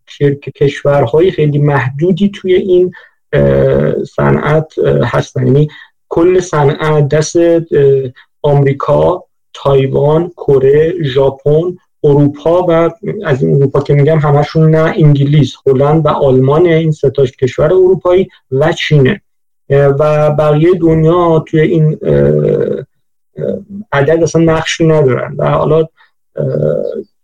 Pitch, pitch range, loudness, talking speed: 150 Hz, 140-165 Hz, -11 LUFS, 100 wpm